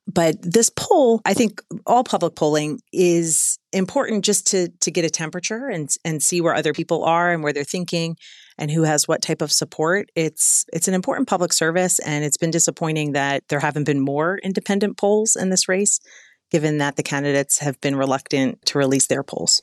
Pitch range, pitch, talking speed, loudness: 150-190 Hz, 165 Hz, 200 wpm, -19 LUFS